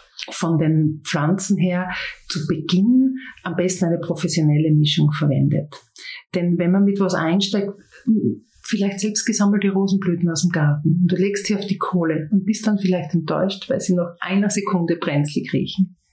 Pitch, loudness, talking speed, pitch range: 180 Hz, -20 LUFS, 165 wpm, 170-200 Hz